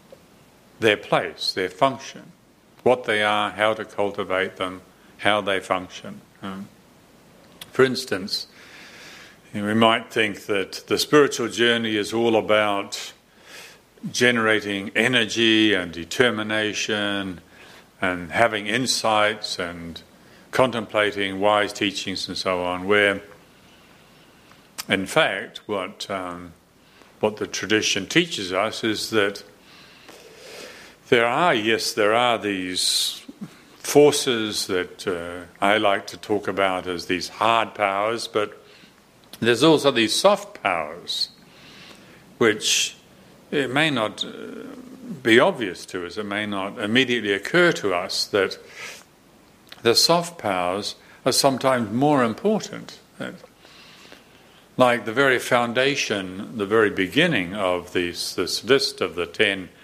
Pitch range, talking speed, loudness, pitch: 100-130 Hz, 115 wpm, -21 LUFS, 110 Hz